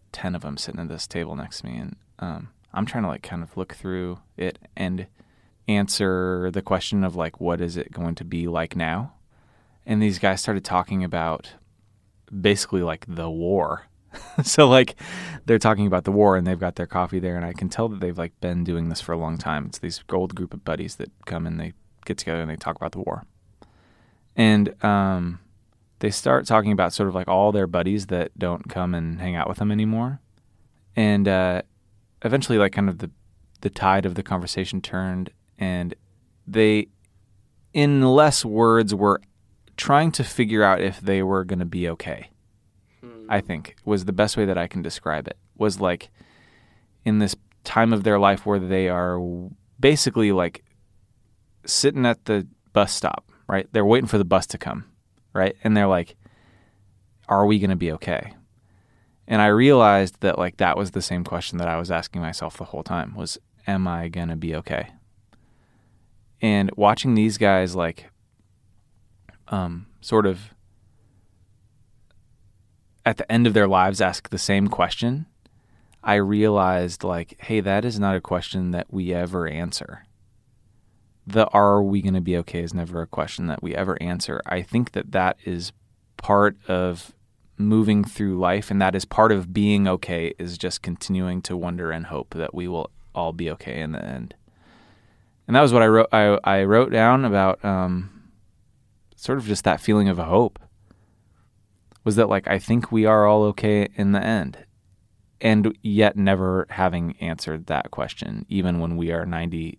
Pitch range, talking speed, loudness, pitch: 90-110 Hz, 185 wpm, -22 LUFS, 100 Hz